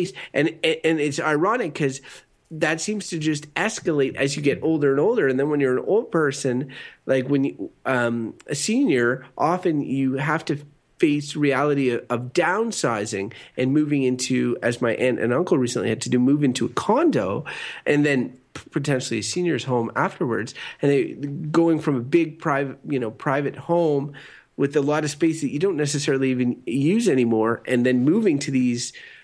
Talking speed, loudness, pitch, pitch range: 185 wpm, -22 LUFS, 140 Hz, 125-155 Hz